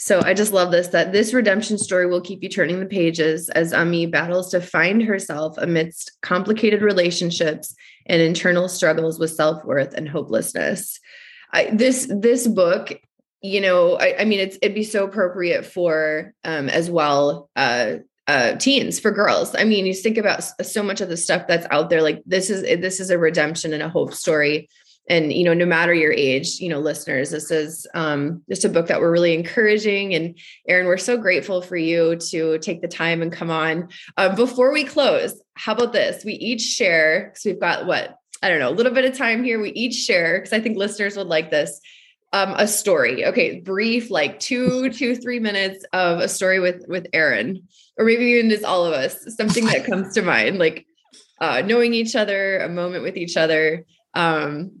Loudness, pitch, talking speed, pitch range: -19 LUFS, 185 Hz, 200 wpm, 165-215 Hz